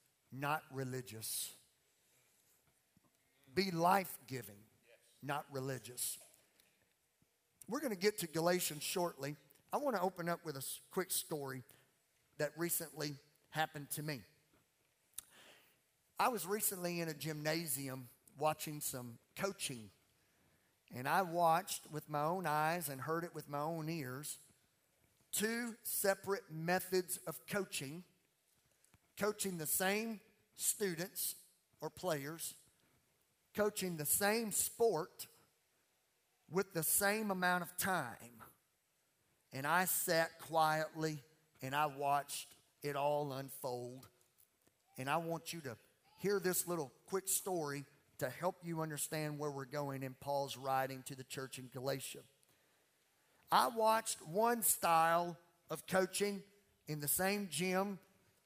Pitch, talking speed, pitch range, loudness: 155 Hz, 120 wpm, 140-185 Hz, -39 LUFS